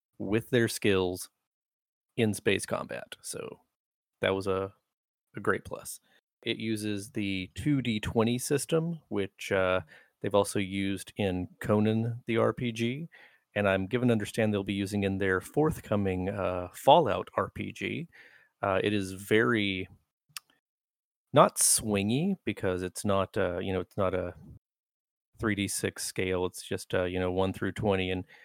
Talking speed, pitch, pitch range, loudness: 140 wpm, 100 Hz, 95-115 Hz, -29 LUFS